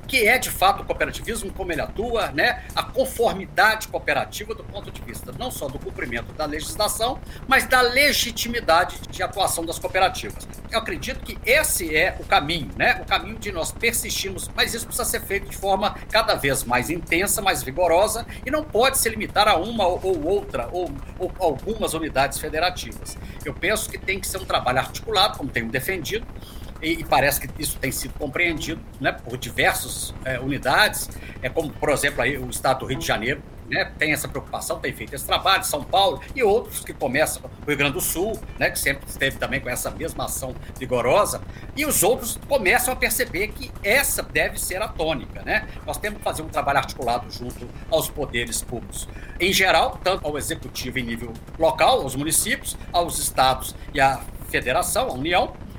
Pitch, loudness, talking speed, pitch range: 145 Hz, -22 LUFS, 190 wpm, 125-180 Hz